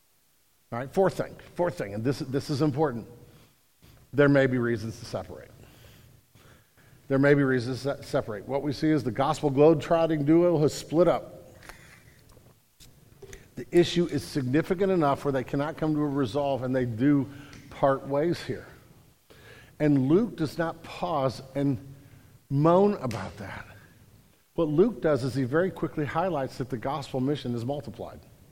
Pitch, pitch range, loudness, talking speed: 140 Hz, 125-155 Hz, -26 LUFS, 160 wpm